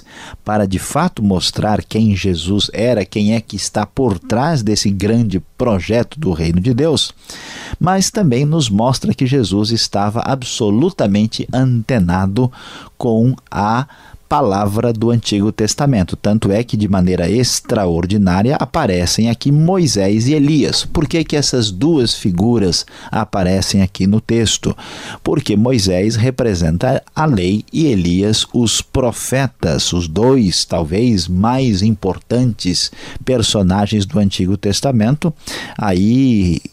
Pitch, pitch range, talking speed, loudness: 110 Hz, 95-125 Hz, 125 wpm, -15 LUFS